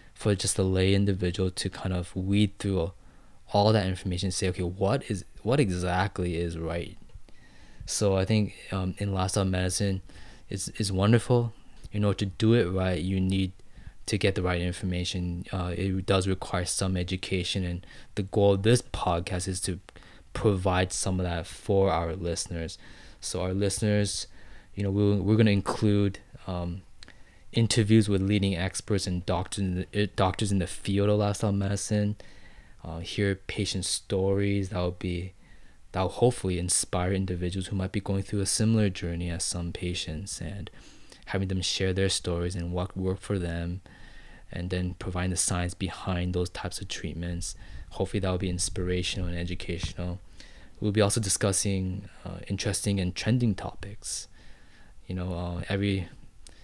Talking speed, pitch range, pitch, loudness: 165 wpm, 90-100 Hz, 95 Hz, -28 LUFS